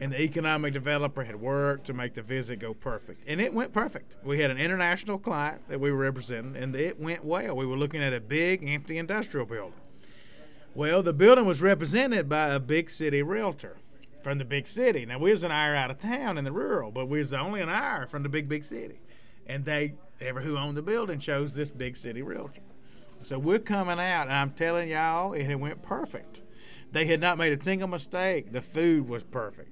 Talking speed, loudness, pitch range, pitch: 220 wpm, -28 LUFS, 135-175 Hz, 150 Hz